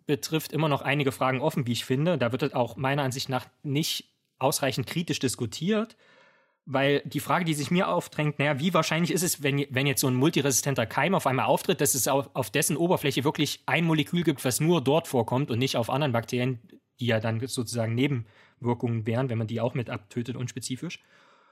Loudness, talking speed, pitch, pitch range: -27 LUFS, 205 wpm, 135 Hz, 125-155 Hz